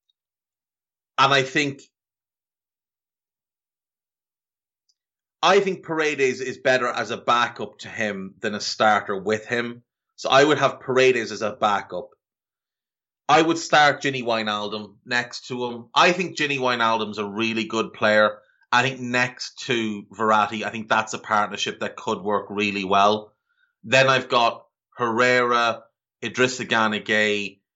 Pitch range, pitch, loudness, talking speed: 105-130 Hz, 115 Hz, -21 LUFS, 135 wpm